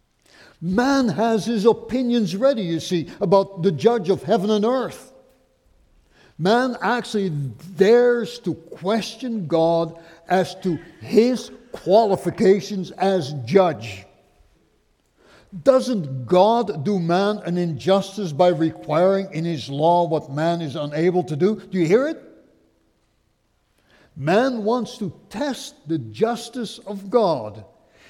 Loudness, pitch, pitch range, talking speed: -21 LUFS, 195 Hz, 170-230 Hz, 115 wpm